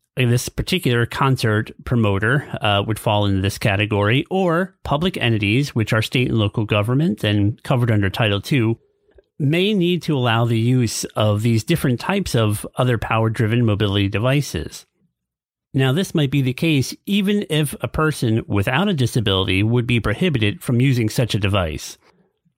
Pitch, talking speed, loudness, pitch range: 120 Hz, 160 wpm, -19 LUFS, 105-145 Hz